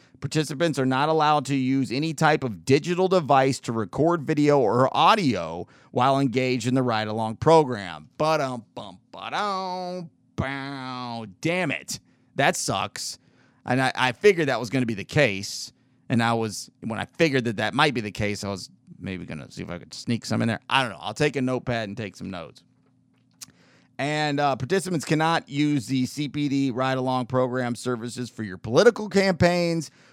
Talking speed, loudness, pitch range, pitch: 180 wpm, -24 LUFS, 120-150 Hz, 130 Hz